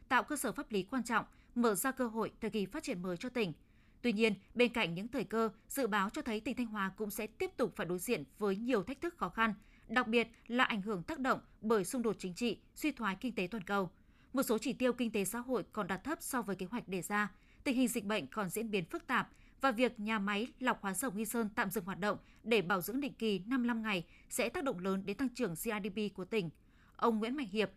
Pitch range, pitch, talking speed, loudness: 205-250 Hz, 225 Hz, 270 wpm, -36 LUFS